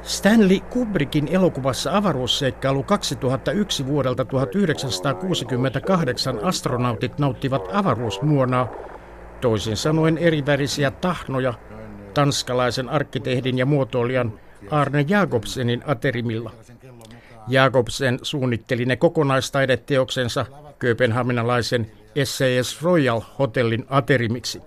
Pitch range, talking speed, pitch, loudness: 125-145 Hz, 75 wpm, 130 Hz, -21 LUFS